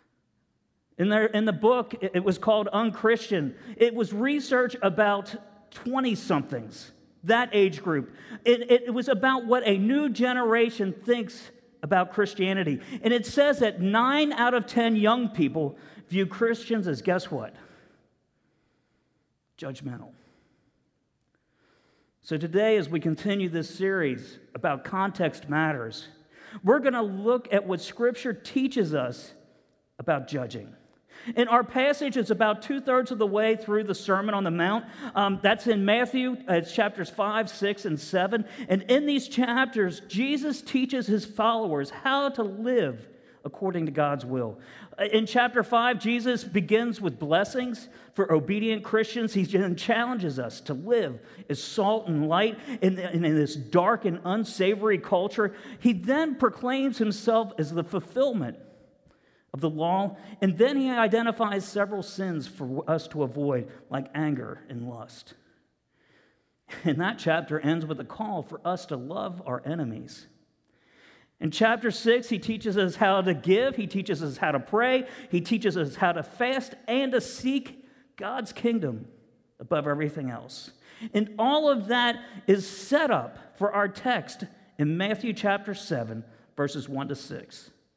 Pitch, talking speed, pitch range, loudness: 205 Hz, 150 wpm, 175-235 Hz, -26 LUFS